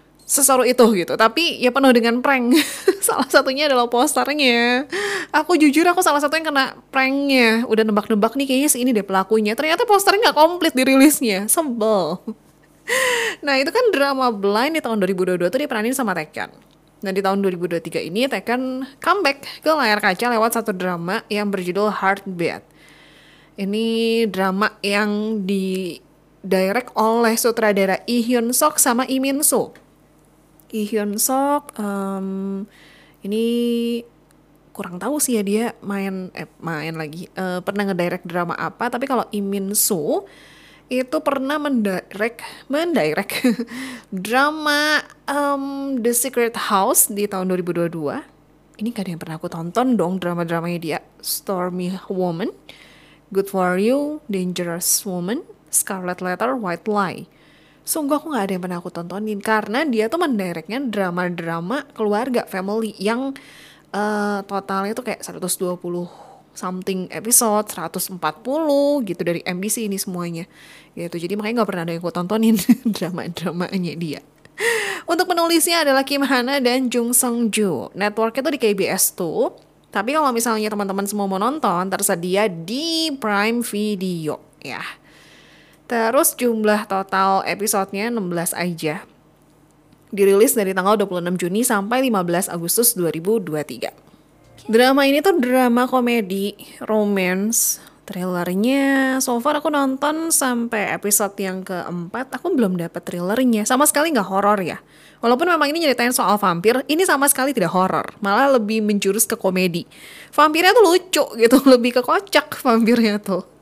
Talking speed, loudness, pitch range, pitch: 135 wpm, -19 LUFS, 185-260 Hz, 215 Hz